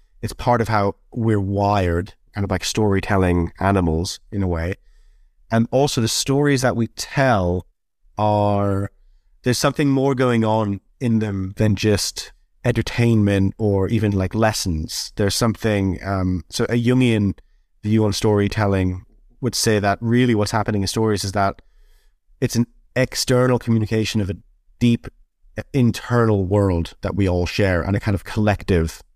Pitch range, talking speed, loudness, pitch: 95-115 Hz, 150 wpm, -20 LUFS, 105 Hz